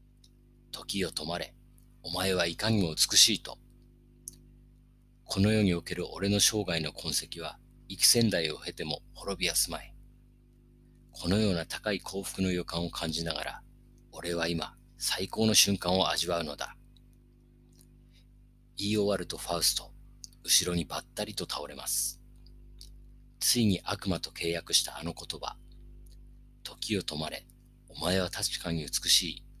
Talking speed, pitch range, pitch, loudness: 255 characters per minute, 85-100 Hz, 90 Hz, -29 LUFS